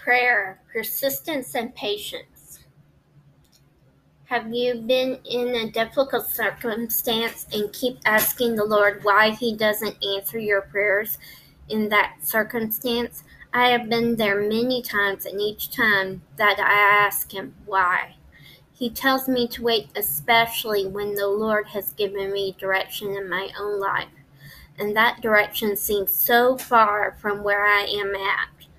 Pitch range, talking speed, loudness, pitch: 200-235 Hz, 140 wpm, -22 LUFS, 210 Hz